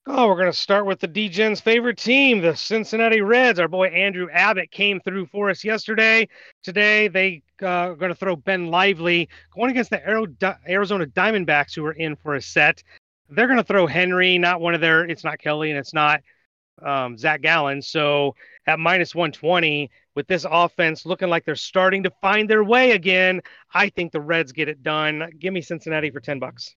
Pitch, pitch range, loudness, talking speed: 180 Hz, 155-200 Hz, -19 LUFS, 200 wpm